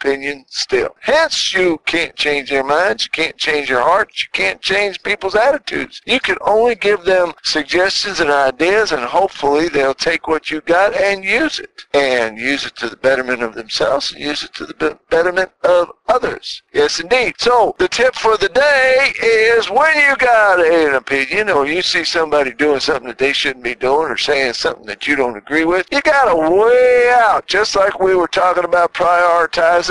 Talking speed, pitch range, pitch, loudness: 195 wpm, 150-240 Hz, 180 Hz, -14 LUFS